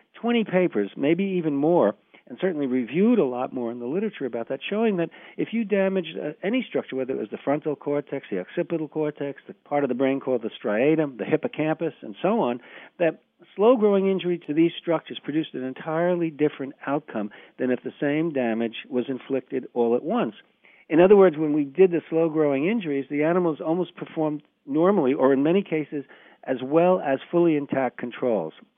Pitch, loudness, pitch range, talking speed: 150 Hz, -24 LUFS, 135-175 Hz, 195 wpm